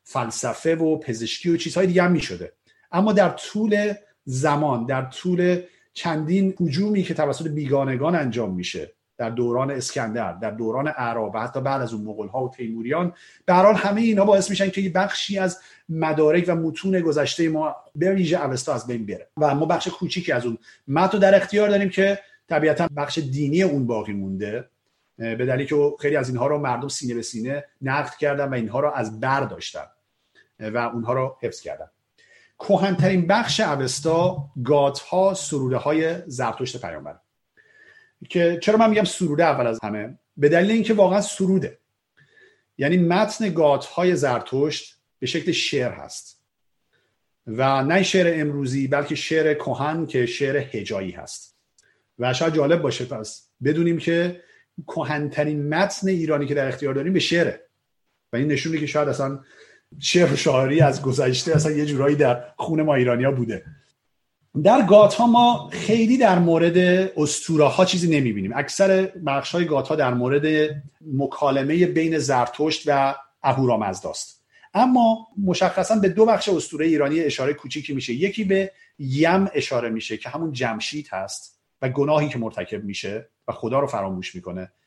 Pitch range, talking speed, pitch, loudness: 130-180 Hz, 155 wpm, 150 Hz, -21 LUFS